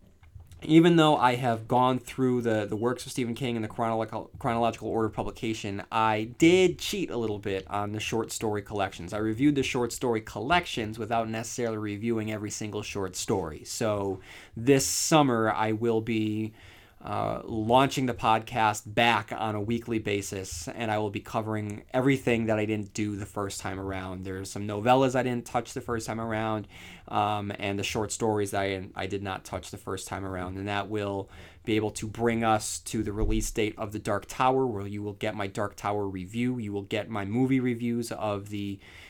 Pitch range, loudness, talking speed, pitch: 100-115 Hz, -28 LUFS, 195 wpm, 110 Hz